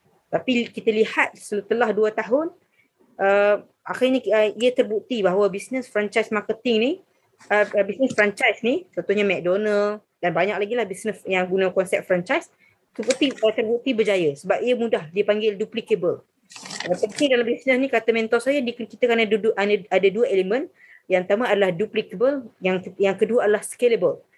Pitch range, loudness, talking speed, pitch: 205-245 Hz, -22 LUFS, 160 wpm, 220 Hz